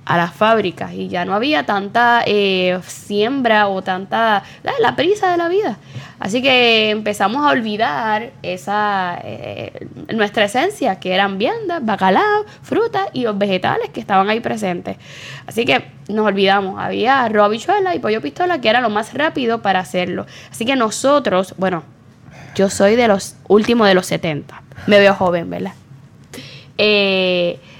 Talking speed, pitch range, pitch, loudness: 155 wpm, 180-230 Hz, 205 Hz, -16 LUFS